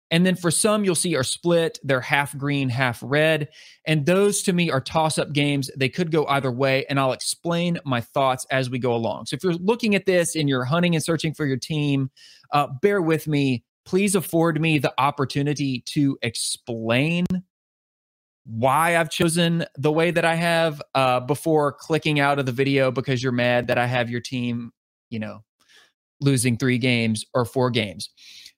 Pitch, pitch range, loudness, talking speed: 145 Hz, 130-165 Hz, -22 LUFS, 190 wpm